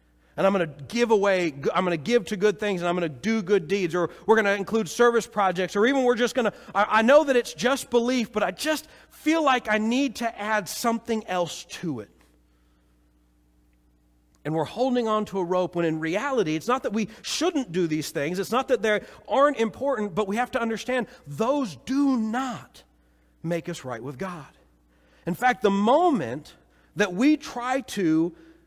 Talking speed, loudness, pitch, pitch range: 195 wpm, -25 LUFS, 205 Hz, 165-240 Hz